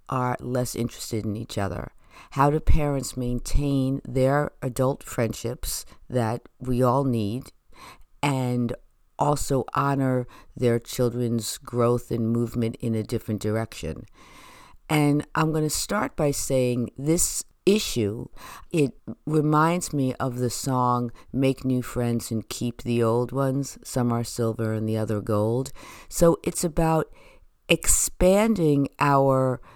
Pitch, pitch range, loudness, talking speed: 125 Hz, 115-140 Hz, -25 LUFS, 130 wpm